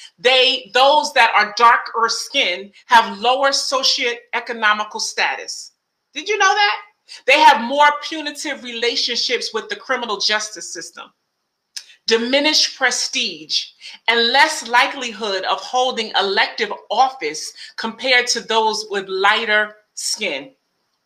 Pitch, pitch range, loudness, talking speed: 245 Hz, 220-275 Hz, -17 LUFS, 110 wpm